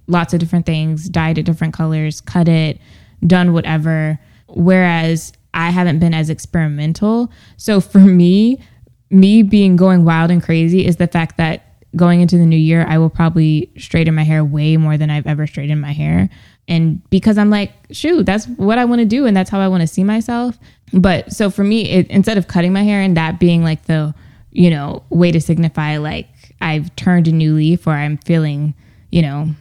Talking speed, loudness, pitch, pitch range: 205 wpm, -14 LUFS, 165 Hz, 155-185 Hz